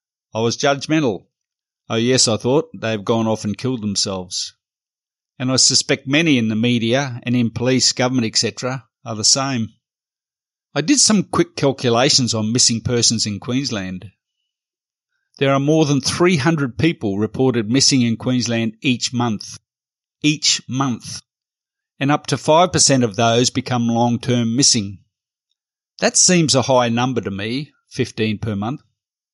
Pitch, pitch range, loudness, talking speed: 125 Hz, 115-135 Hz, -17 LUFS, 150 wpm